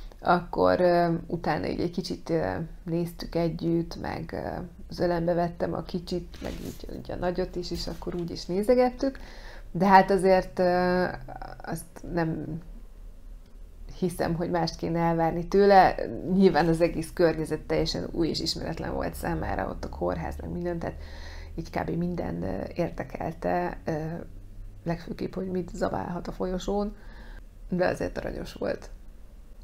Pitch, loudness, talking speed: 170 Hz, -28 LUFS, 130 wpm